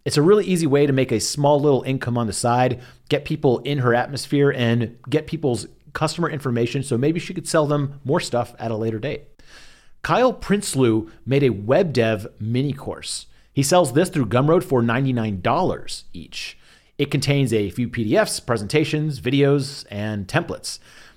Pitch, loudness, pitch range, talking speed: 135 Hz, -21 LUFS, 120-150 Hz, 175 wpm